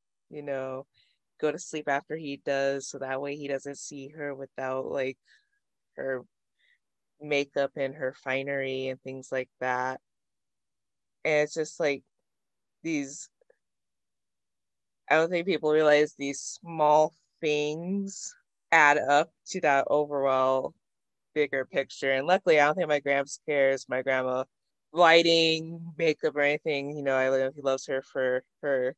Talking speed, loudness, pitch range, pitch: 145 wpm, -27 LUFS, 130-155 Hz, 140 Hz